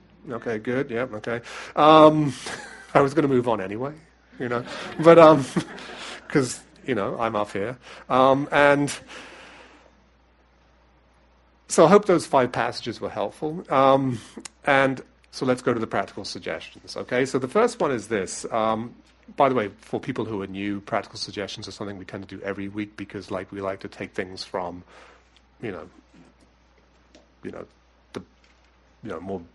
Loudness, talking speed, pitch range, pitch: -22 LUFS, 170 wpm, 90-135 Hz, 105 Hz